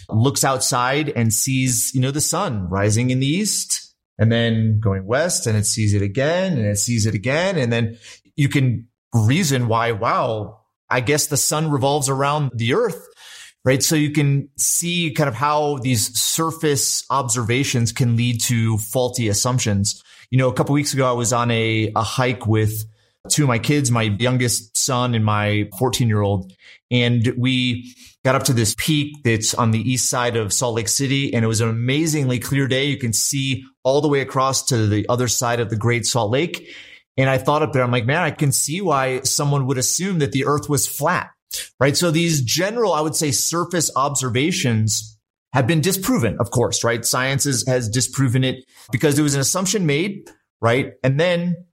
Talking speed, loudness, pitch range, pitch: 200 wpm, -19 LUFS, 115-145 Hz, 130 Hz